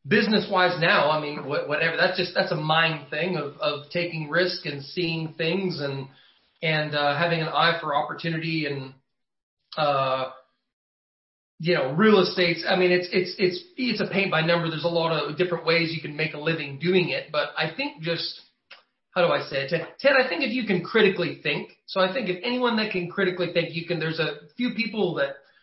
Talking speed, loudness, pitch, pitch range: 210 wpm, -24 LUFS, 170 Hz, 155-185 Hz